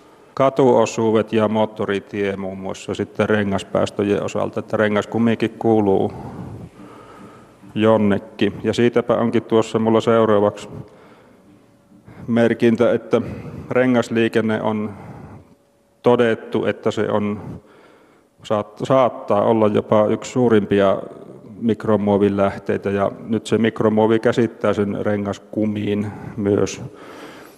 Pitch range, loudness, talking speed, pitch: 105-115 Hz, -19 LUFS, 90 wpm, 110 Hz